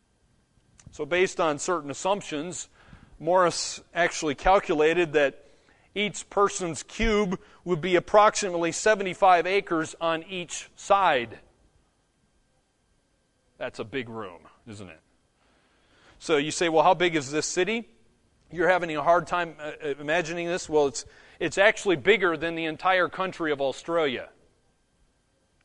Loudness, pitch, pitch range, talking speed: -25 LUFS, 170 Hz, 150-185 Hz, 125 wpm